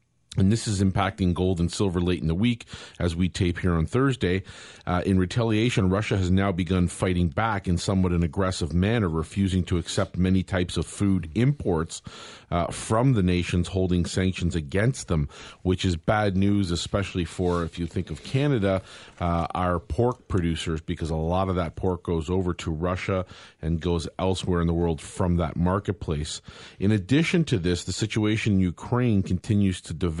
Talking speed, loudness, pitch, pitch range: 185 wpm, -25 LUFS, 95 Hz, 85-100 Hz